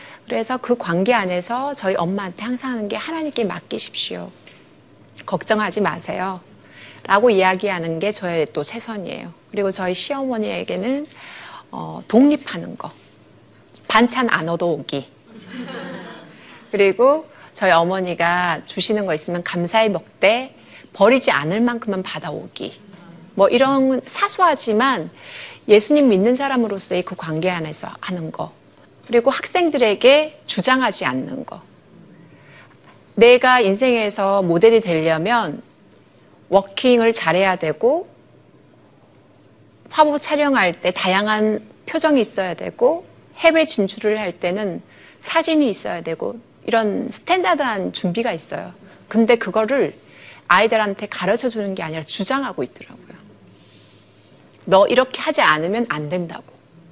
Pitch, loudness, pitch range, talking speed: 215 Hz, -18 LUFS, 180-255 Hz, 275 characters per minute